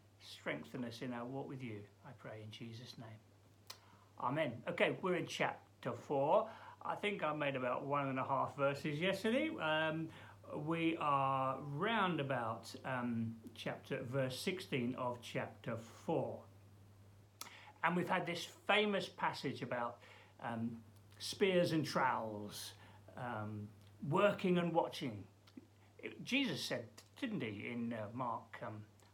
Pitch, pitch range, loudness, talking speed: 125 Hz, 105-155 Hz, -40 LUFS, 130 wpm